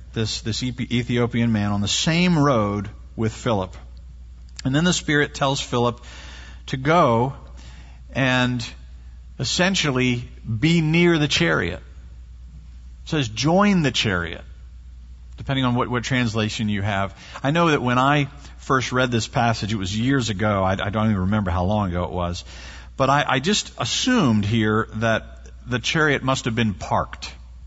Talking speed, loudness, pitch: 155 wpm, -21 LUFS, 110 Hz